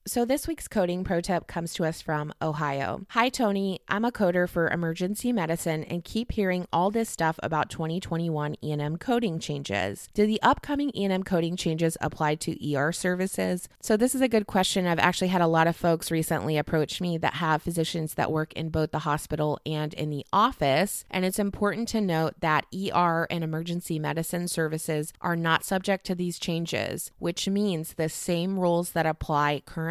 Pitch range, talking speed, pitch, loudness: 155-190 Hz, 190 wpm, 170 Hz, -27 LUFS